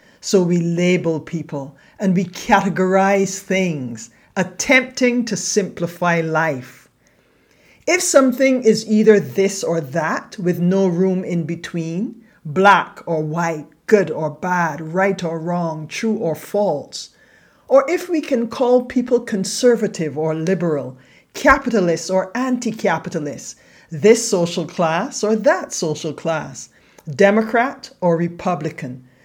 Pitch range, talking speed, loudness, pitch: 165-220 Hz, 120 wpm, -18 LUFS, 185 Hz